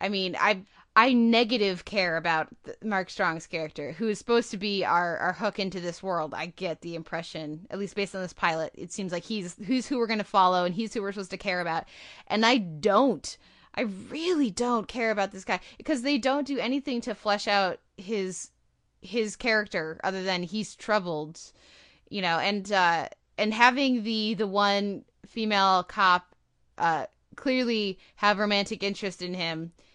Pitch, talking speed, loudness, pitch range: 200 Hz, 180 wpm, -27 LUFS, 180-225 Hz